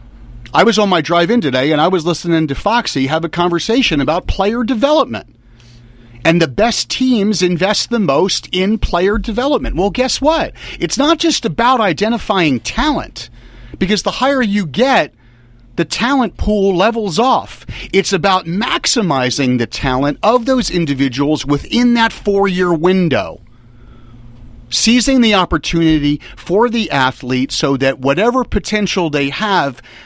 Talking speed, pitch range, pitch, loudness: 145 wpm, 135-225 Hz, 175 Hz, -14 LUFS